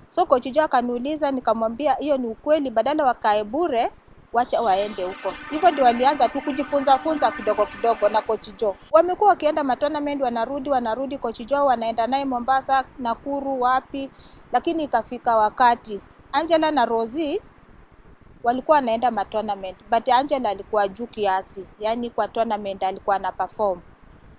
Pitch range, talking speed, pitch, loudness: 215-285 Hz, 130 wpm, 245 Hz, -22 LUFS